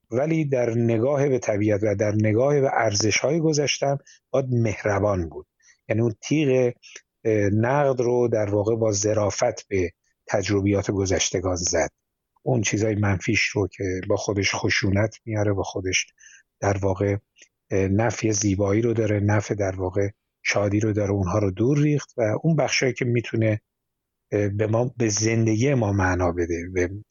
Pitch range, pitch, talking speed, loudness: 100-120 Hz, 105 Hz, 150 wpm, -23 LUFS